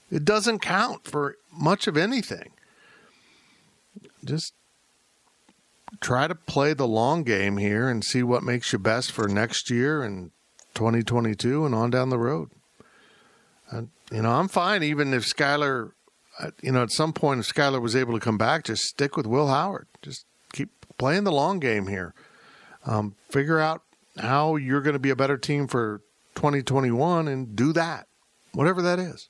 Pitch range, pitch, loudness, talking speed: 115-155 Hz, 135 Hz, -25 LUFS, 170 wpm